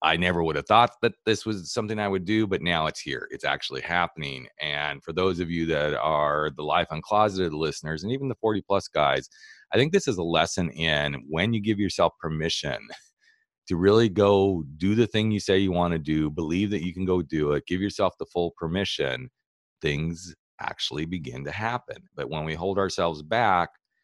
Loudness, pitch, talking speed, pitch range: -26 LUFS, 90 Hz, 205 wpm, 80-105 Hz